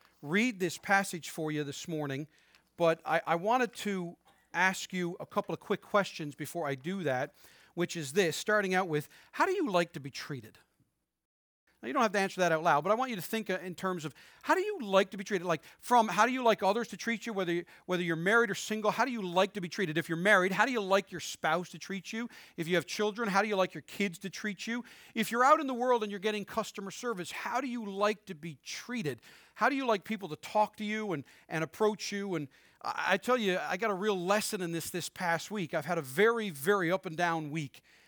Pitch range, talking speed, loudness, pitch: 170-215 Hz, 255 wpm, -32 LUFS, 195 Hz